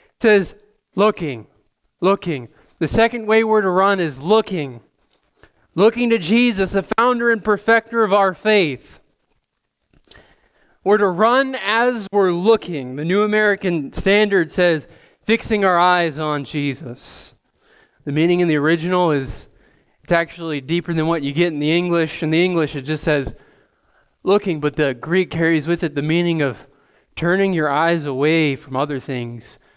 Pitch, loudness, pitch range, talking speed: 170 Hz, -18 LUFS, 150-205 Hz, 155 wpm